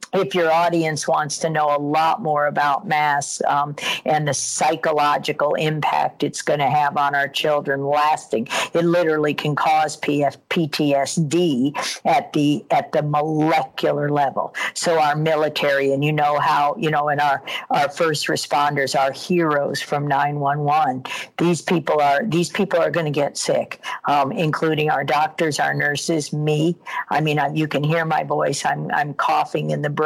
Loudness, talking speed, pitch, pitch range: -20 LUFS, 165 wpm, 150 Hz, 145-160 Hz